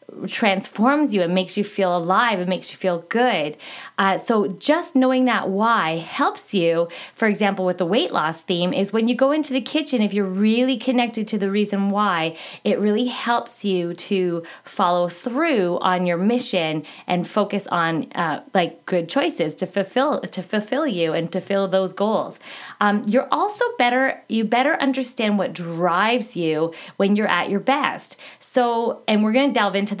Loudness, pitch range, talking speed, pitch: -21 LUFS, 180-245 Hz, 180 wpm, 205 Hz